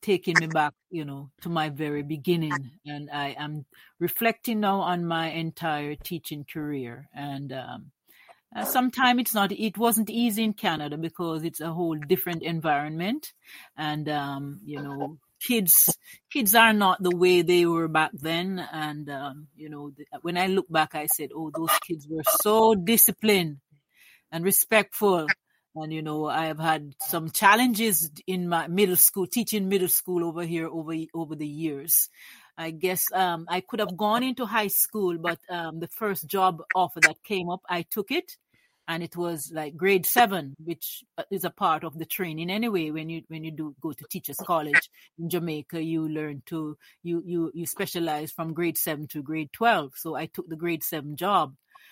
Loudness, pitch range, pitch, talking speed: -25 LUFS, 155-190 Hz, 165 Hz, 180 wpm